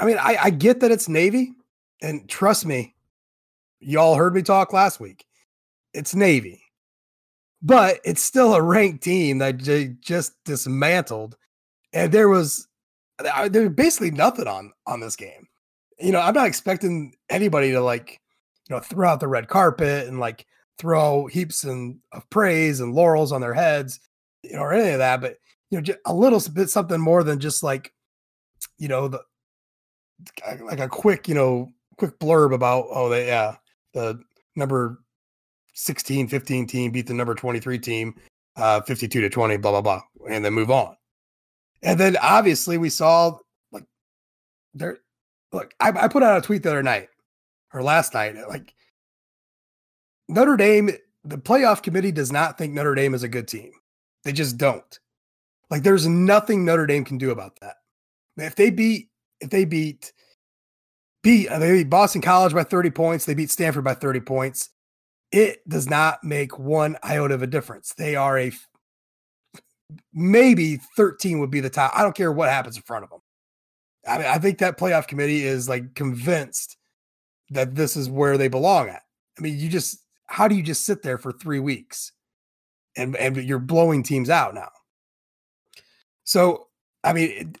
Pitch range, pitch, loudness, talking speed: 125-180 Hz, 150 Hz, -20 LUFS, 175 wpm